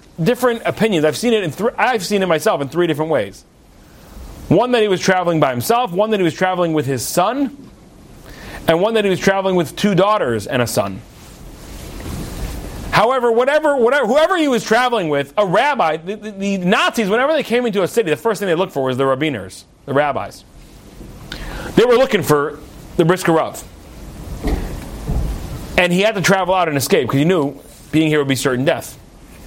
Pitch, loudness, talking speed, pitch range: 185 Hz, -16 LUFS, 195 wpm, 150-220 Hz